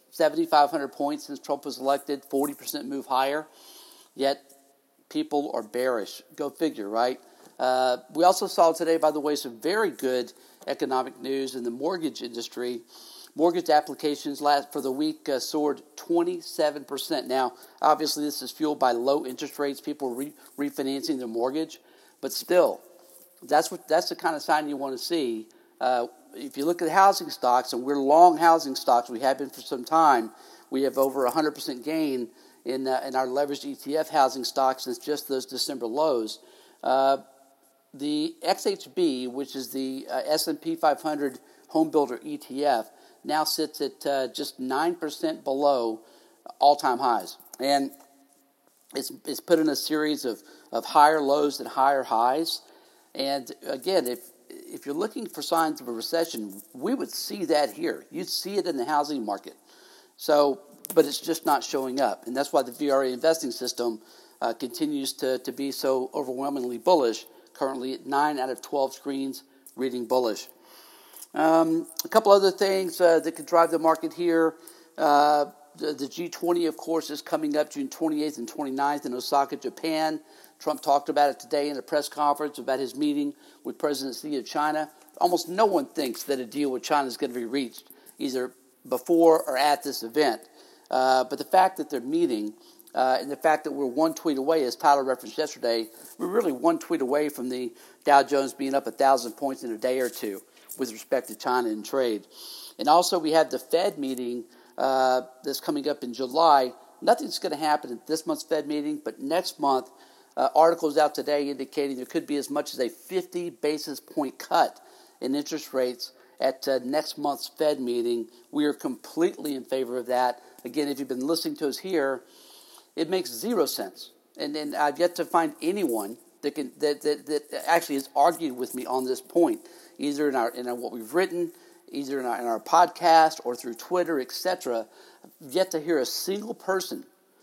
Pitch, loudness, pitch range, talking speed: 145 Hz, -26 LUFS, 130-160 Hz, 185 wpm